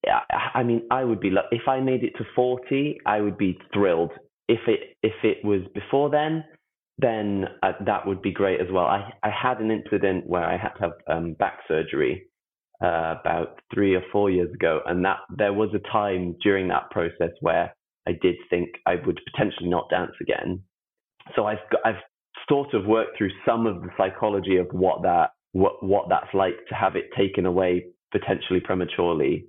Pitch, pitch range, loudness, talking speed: 100 Hz, 95-115 Hz, -24 LUFS, 195 wpm